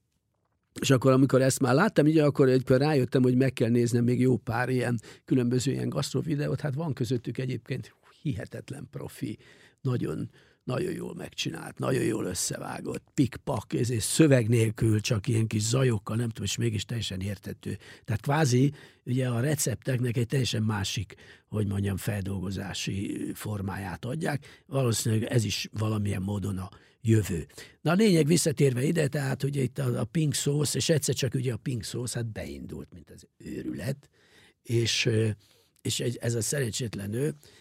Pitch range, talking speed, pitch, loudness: 110-135 Hz, 155 wpm, 125 Hz, -28 LUFS